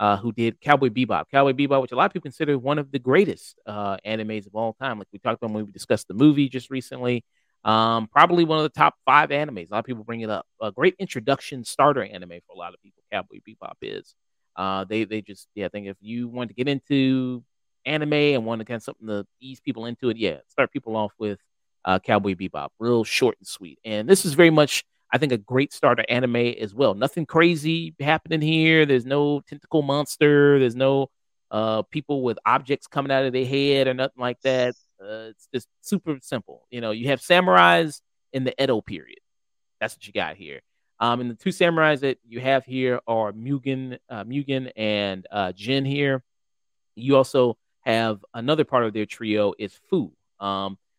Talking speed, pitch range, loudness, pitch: 210 wpm, 110-140 Hz, -23 LUFS, 125 Hz